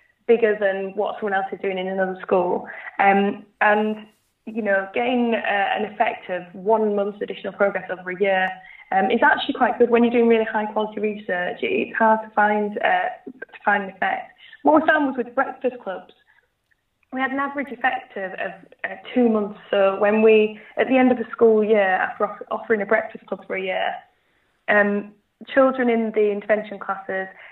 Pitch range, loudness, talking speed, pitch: 200-240 Hz, -21 LUFS, 190 wpm, 215 Hz